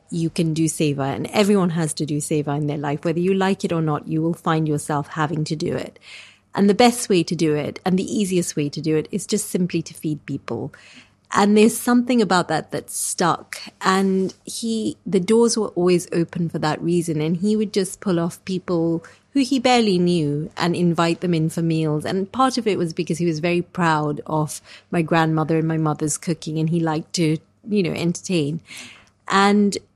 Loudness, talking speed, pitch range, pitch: -21 LUFS, 210 wpm, 155-195 Hz, 170 Hz